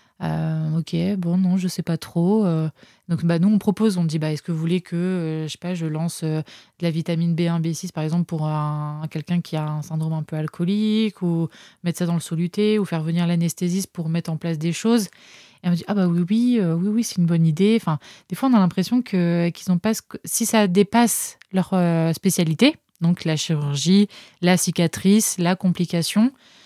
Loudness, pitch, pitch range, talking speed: -22 LUFS, 175 Hz, 165-190 Hz, 225 wpm